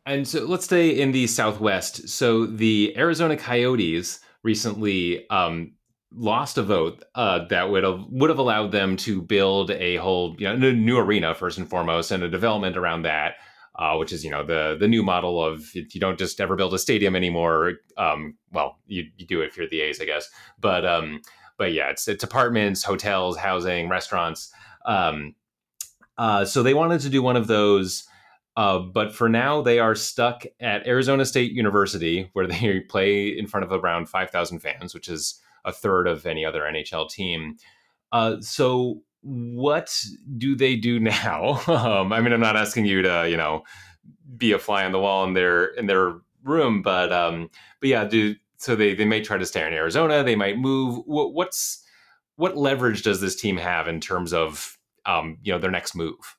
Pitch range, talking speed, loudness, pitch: 90-120 Hz, 195 wpm, -23 LUFS, 105 Hz